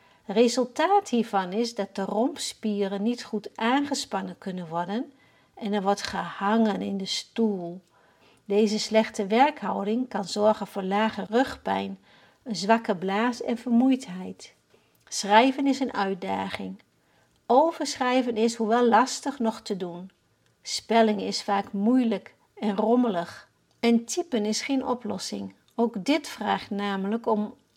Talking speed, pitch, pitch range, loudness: 125 wpm, 215 Hz, 200-240 Hz, -26 LUFS